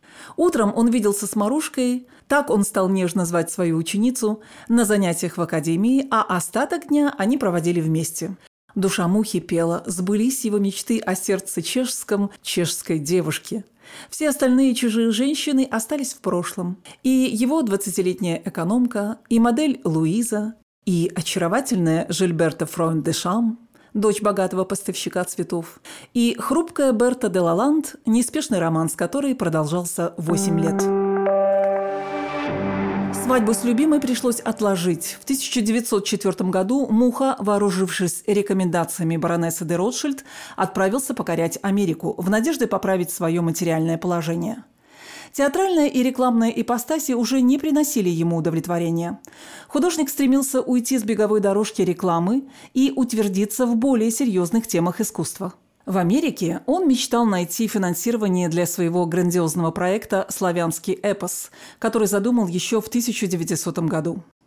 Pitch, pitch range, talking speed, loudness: 205 Hz, 175-245 Hz, 120 wpm, -21 LUFS